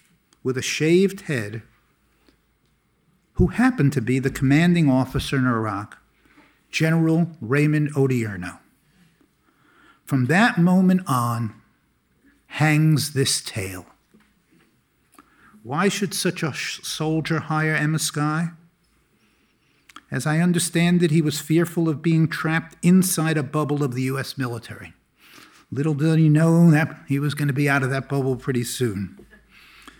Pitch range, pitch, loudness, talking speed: 130-165 Hz, 150 Hz, -21 LUFS, 130 wpm